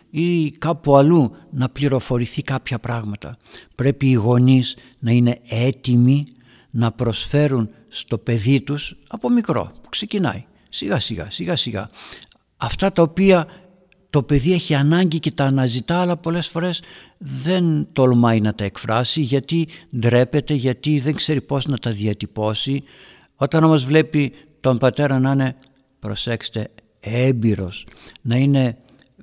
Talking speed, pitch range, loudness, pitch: 130 wpm, 120-155 Hz, -19 LUFS, 135 Hz